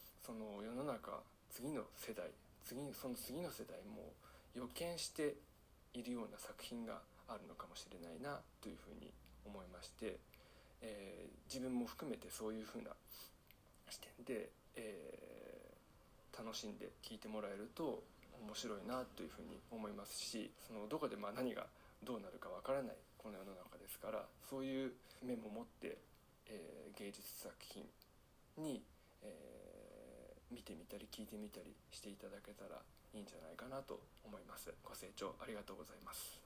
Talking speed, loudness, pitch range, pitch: 310 characters per minute, -51 LUFS, 105-135 Hz, 125 Hz